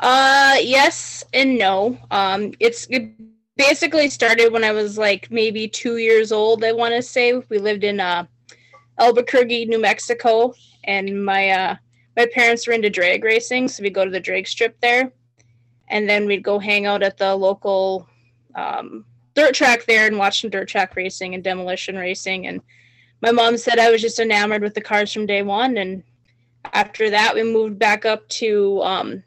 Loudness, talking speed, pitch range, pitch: -18 LUFS, 185 wpm, 190-230 Hz, 210 Hz